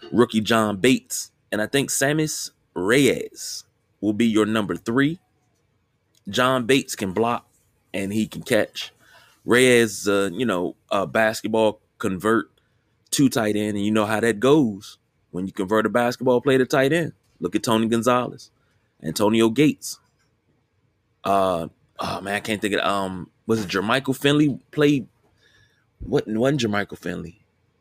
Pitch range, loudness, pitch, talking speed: 105-125 Hz, -22 LUFS, 110 Hz, 150 wpm